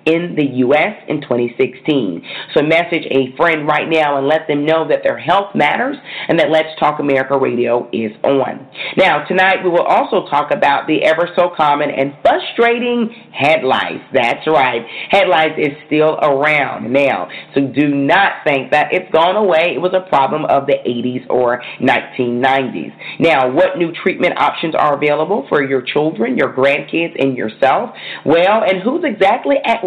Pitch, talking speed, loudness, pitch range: 150 Hz, 165 wpm, -14 LUFS, 135-170 Hz